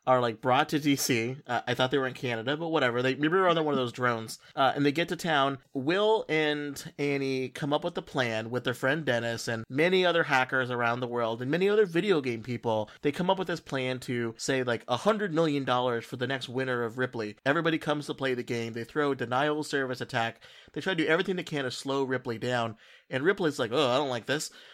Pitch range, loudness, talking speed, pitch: 125-155 Hz, -29 LUFS, 250 wpm, 130 Hz